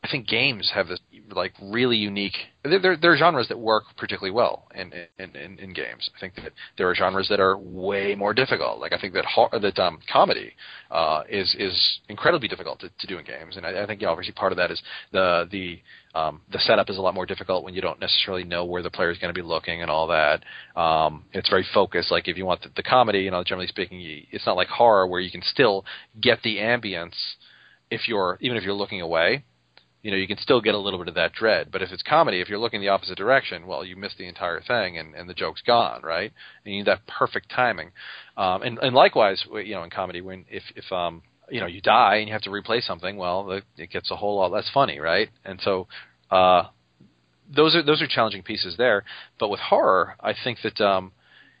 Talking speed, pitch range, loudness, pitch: 240 wpm, 90-110 Hz, -23 LUFS, 100 Hz